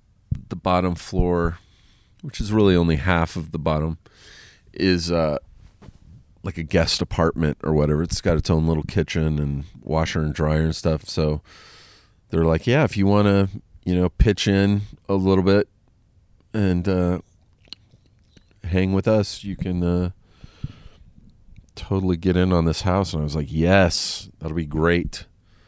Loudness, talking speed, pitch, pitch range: -22 LUFS, 160 wpm, 90 Hz, 80-100 Hz